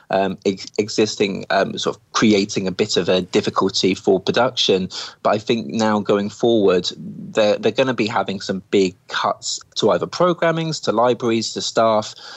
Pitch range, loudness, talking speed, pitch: 100-125 Hz, -19 LUFS, 170 wpm, 110 Hz